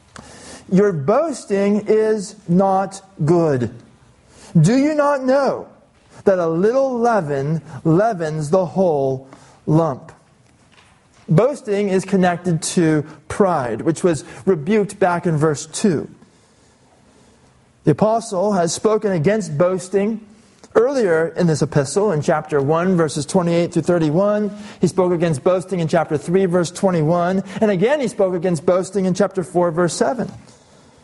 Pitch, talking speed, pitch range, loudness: 180 Hz, 130 wpm, 160-205 Hz, -18 LUFS